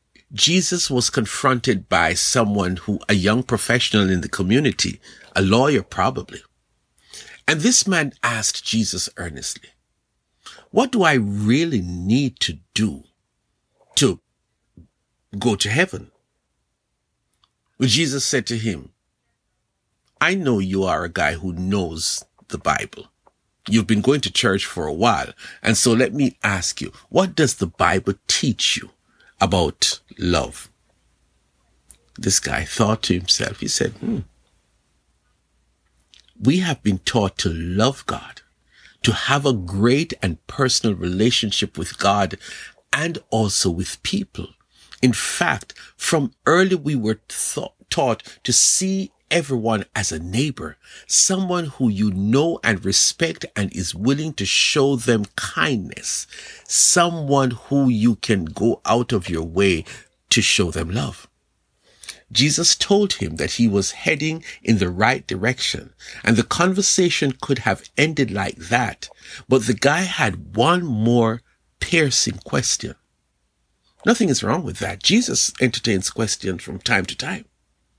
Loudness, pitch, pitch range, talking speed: -19 LUFS, 115 Hz, 95-140 Hz, 135 wpm